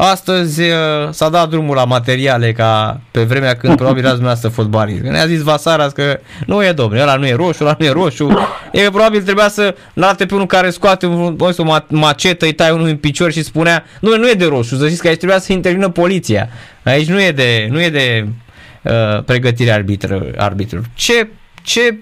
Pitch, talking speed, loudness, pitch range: 155 Hz, 205 wpm, -12 LUFS, 125-180 Hz